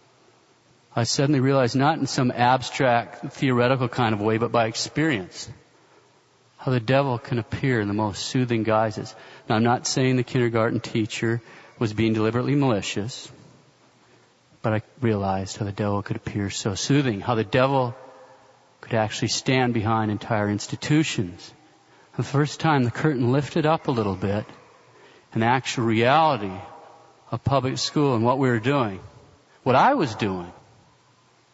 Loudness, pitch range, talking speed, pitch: -23 LUFS, 110-135 Hz, 150 wpm, 120 Hz